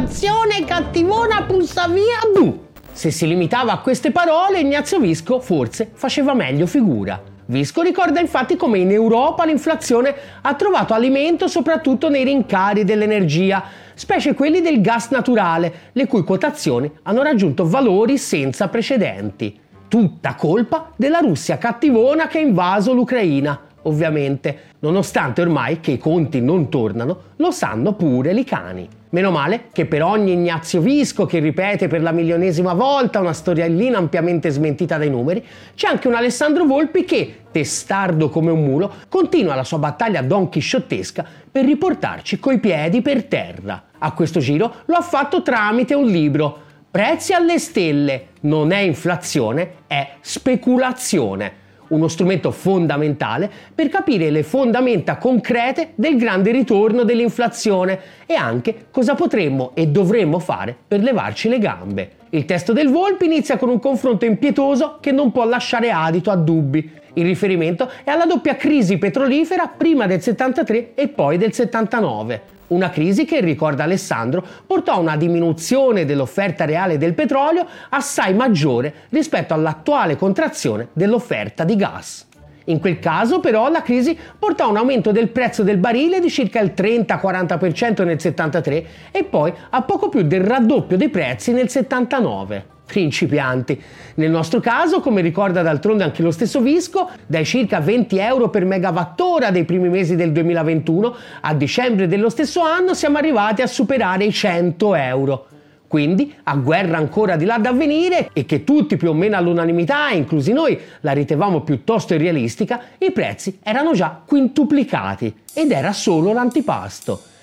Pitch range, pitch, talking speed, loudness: 165-270 Hz, 205 Hz, 150 wpm, -17 LUFS